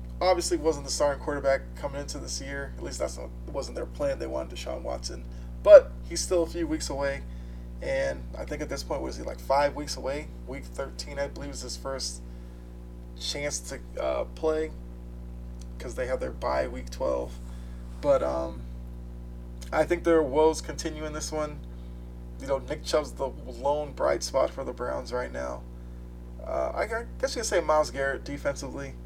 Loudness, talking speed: -28 LUFS, 180 wpm